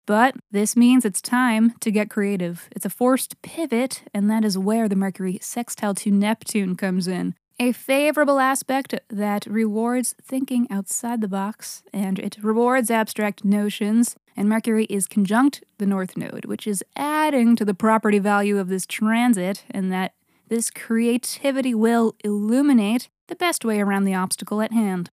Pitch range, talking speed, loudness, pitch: 205-245 Hz, 160 wpm, -22 LUFS, 220 Hz